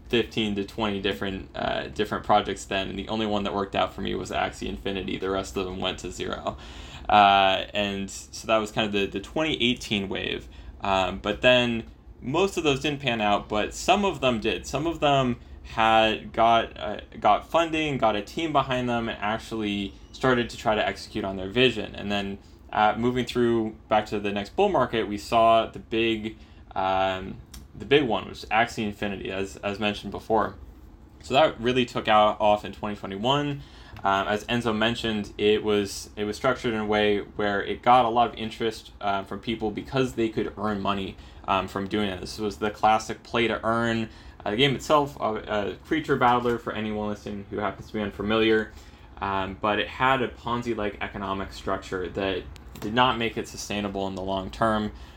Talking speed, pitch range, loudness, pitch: 200 wpm, 100-115 Hz, -25 LUFS, 105 Hz